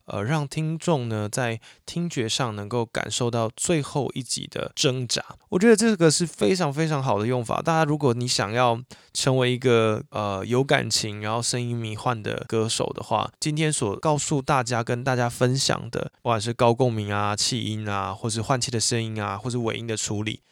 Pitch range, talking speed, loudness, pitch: 110-145 Hz, 290 characters per minute, -24 LUFS, 125 Hz